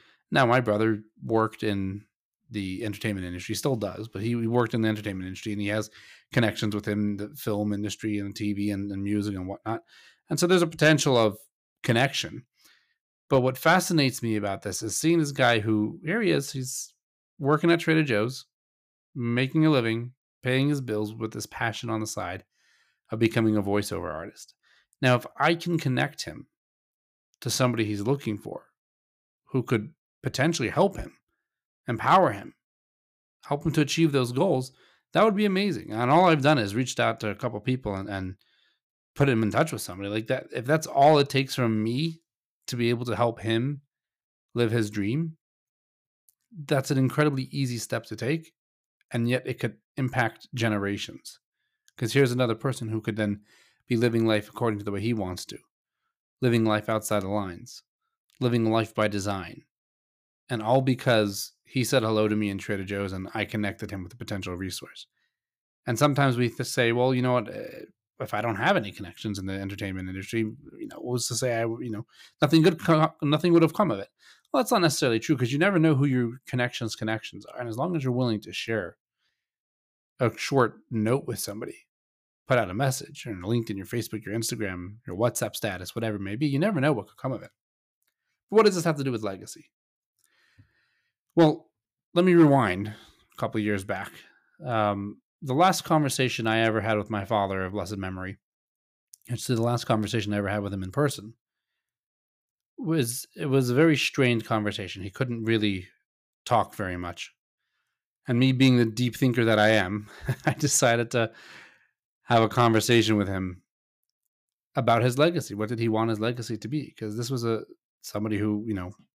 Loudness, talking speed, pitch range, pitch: -26 LUFS, 190 wpm, 105-135 Hz, 115 Hz